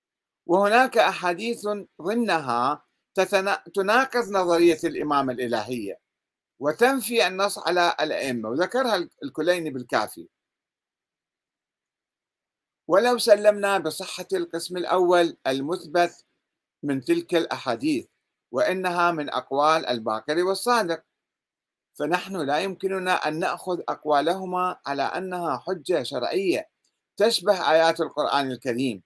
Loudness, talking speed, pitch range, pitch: -24 LUFS, 85 wpm, 155-200 Hz, 180 Hz